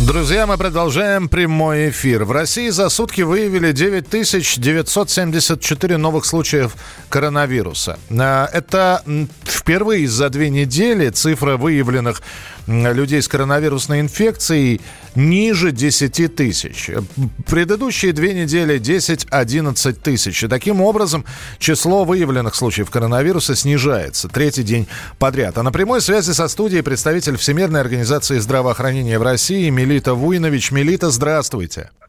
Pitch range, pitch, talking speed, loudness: 130-175 Hz, 150 Hz, 110 wpm, -16 LUFS